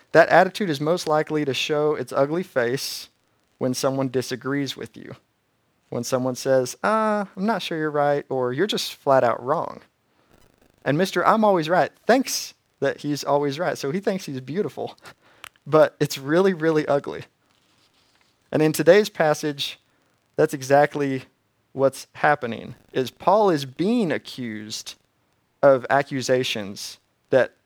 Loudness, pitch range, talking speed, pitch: -22 LUFS, 130-160 Hz, 145 wpm, 145 Hz